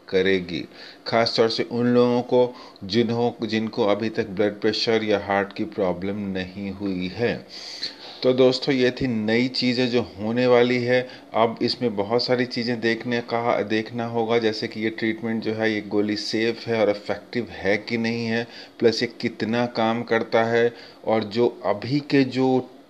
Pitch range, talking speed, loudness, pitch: 110-120 Hz, 170 wpm, -23 LUFS, 115 Hz